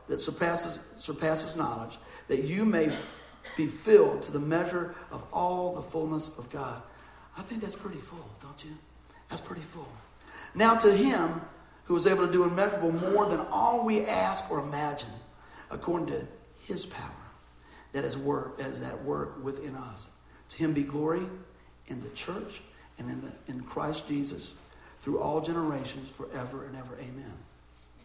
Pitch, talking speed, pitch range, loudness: 150 Hz, 160 wpm, 130-175 Hz, -30 LUFS